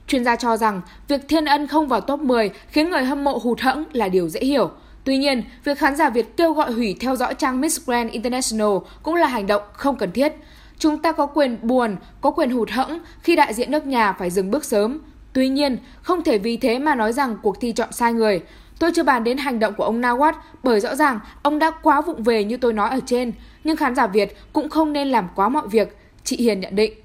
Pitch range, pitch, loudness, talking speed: 225-295 Hz, 255 Hz, -20 LUFS, 250 wpm